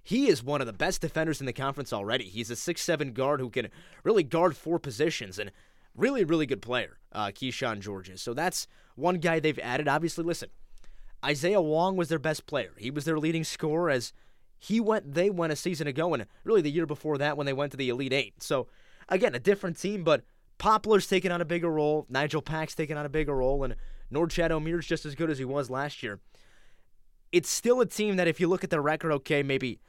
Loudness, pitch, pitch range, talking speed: -29 LUFS, 155 Hz, 135-170 Hz, 225 wpm